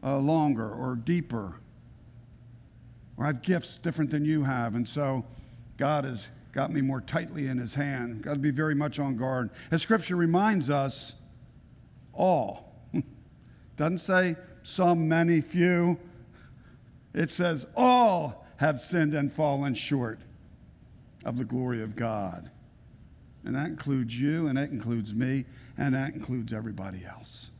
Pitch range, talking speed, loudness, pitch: 120-155 Hz, 145 wpm, -29 LUFS, 135 Hz